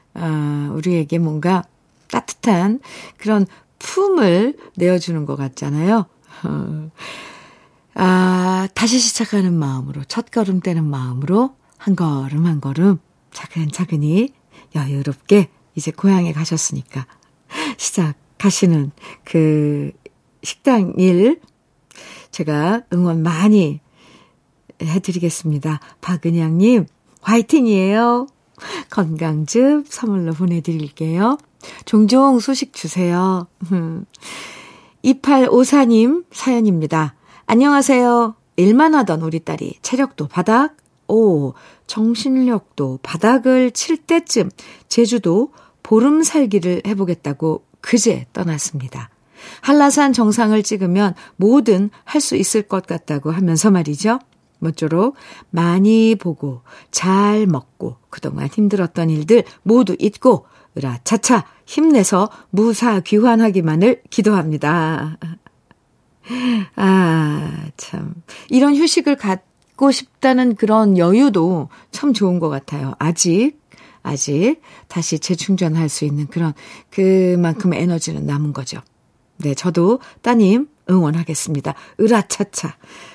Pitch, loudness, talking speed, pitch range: 185 Hz, -17 LUFS, 220 characters per minute, 160-230 Hz